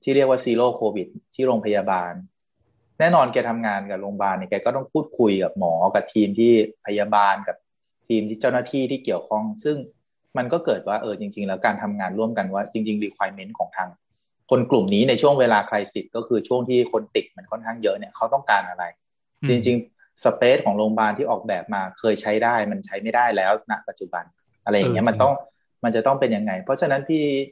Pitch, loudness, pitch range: 110 Hz, -22 LUFS, 105-125 Hz